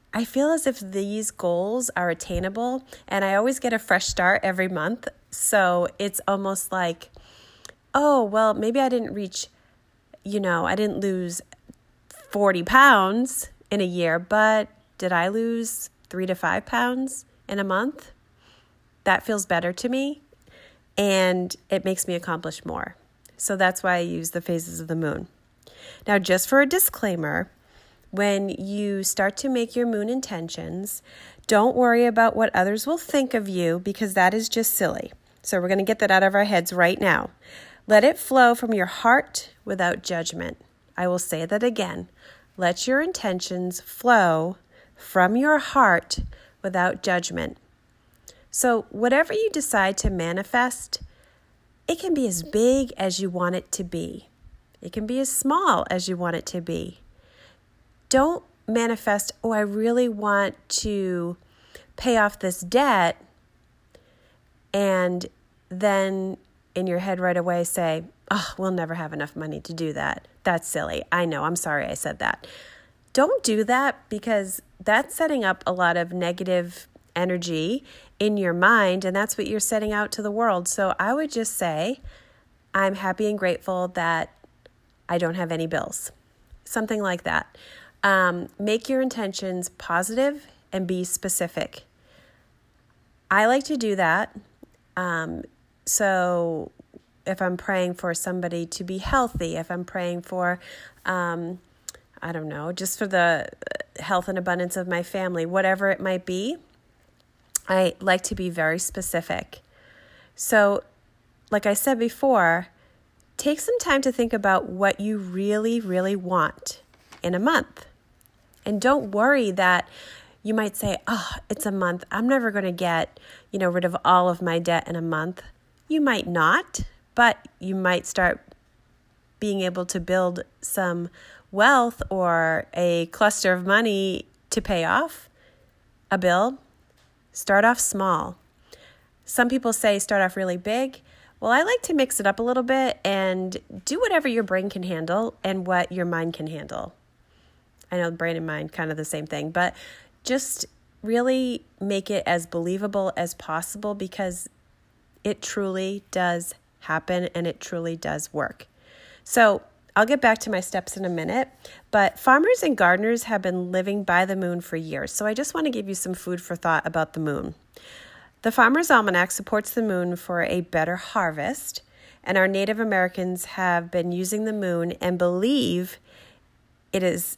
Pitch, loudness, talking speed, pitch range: 190 Hz, -23 LUFS, 160 wpm, 175-225 Hz